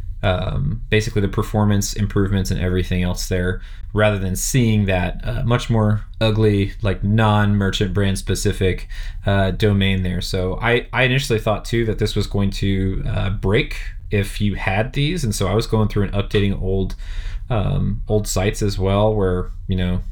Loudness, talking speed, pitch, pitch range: -20 LUFS, 175 wpm, 100 Hz, 95-110 Hz